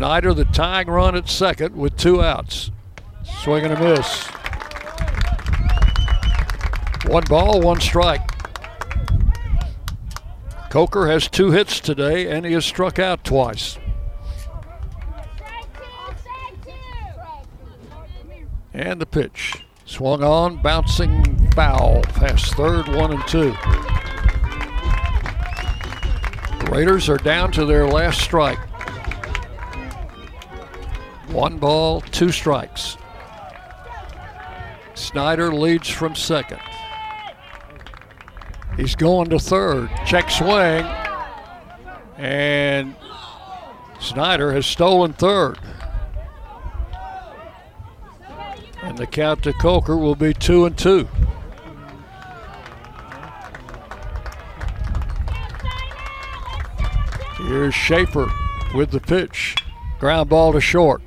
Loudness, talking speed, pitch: -19 LUFS, 85 wpm, 130 Hz